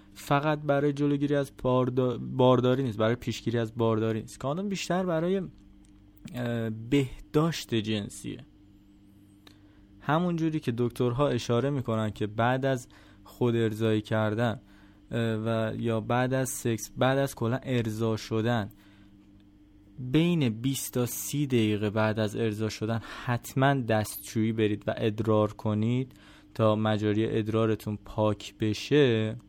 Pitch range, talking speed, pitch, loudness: 105-130 Hz, 120 wpm, 115 Hz, -28 LUFS